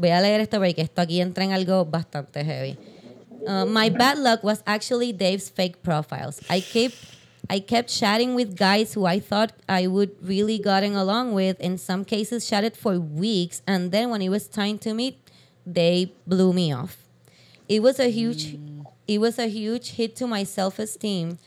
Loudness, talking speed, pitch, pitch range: -23 LUFS, 150 wpm, 195 Hz, 180-220 Hz